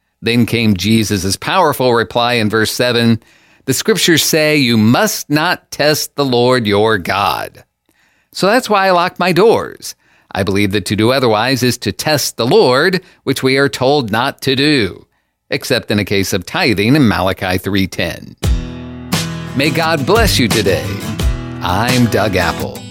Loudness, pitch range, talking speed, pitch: -13 LUFS, 105-150 Hz, 160 wpm, 120 Hz